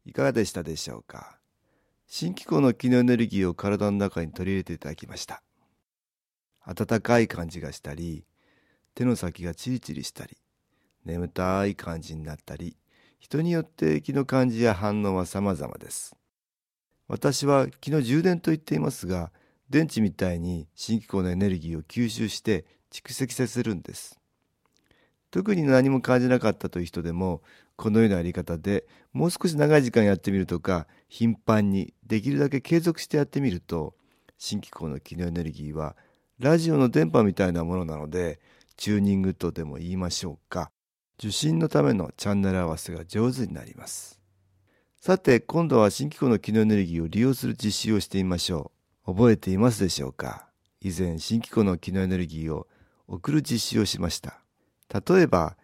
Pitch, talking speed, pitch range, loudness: 100 Hz, 355 characters per minute, 85-125 Hz, -26 LUFS